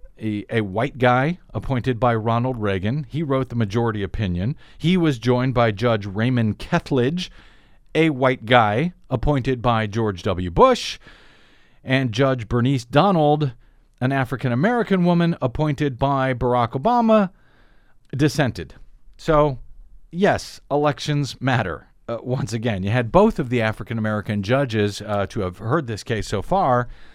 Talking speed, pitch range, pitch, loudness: 140 wpm, 115-145 Hz, 125 Hz, -21 LUFS